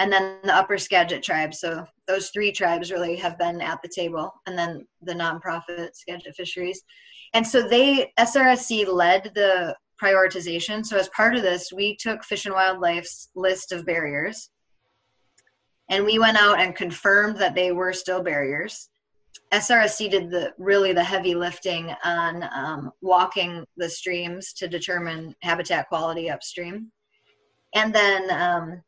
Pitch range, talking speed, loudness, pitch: 175-200 Hz, 150 wpm, -22 LUFS, 185 Hz